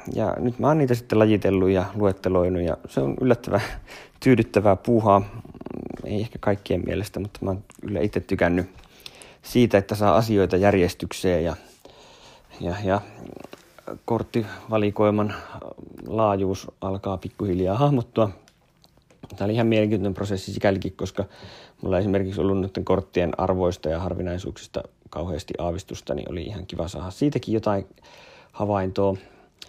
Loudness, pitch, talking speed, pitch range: -24 LUFS, 100 Hz, 125 wpm, 95-110 Hz